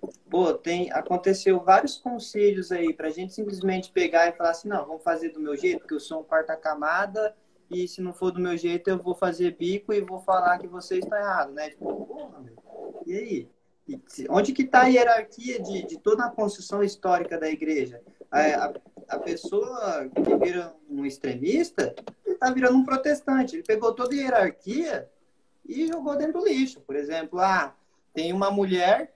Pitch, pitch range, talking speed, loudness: 195 Hz, 175-260 Hz, 180 wpm, -25 LUFS